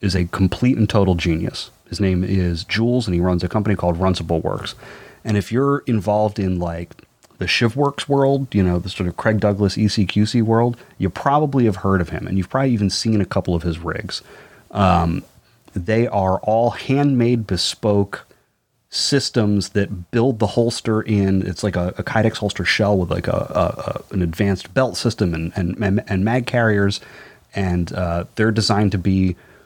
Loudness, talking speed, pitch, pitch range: -19 LUFS, 185 wpm, 100 Hz, 90-115 Hz